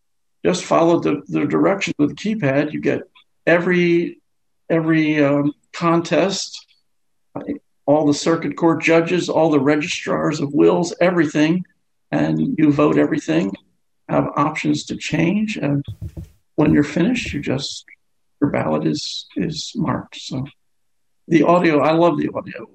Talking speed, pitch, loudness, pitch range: 135 wpm, 155 Hz, -18 LUFS, 145-170 Hz